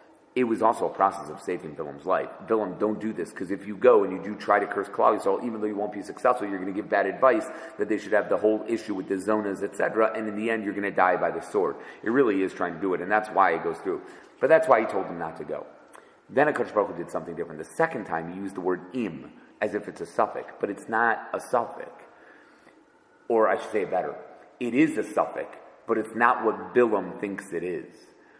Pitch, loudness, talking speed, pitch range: 105 Hz, -26 LUFS, 260 wpm, 100-115 Hz